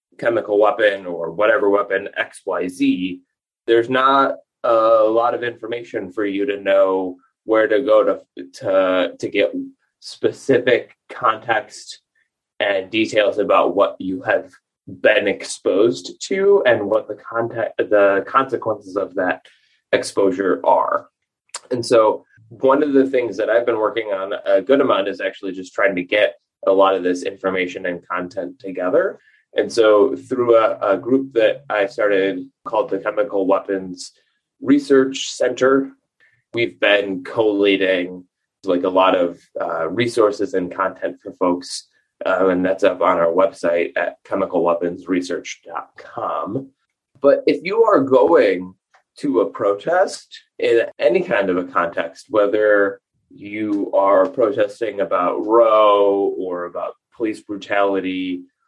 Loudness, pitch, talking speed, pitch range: -18 LUFS, 105 Hz, 135 wpm, 95-135 Hz